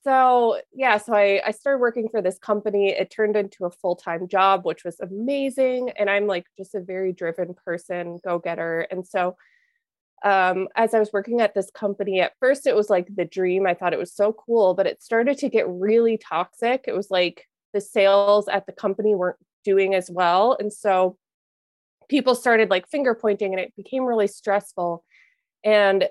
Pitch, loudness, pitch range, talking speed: 200 Hz, -22 LUFS, 185-225 Hz, 190 wpm